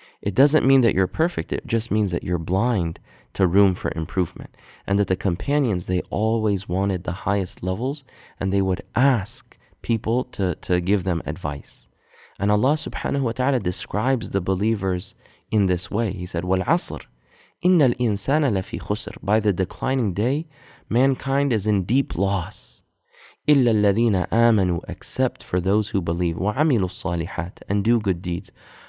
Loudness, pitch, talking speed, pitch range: -23 LUFS, 100 Hz, 155 wpm, 90-120 Hz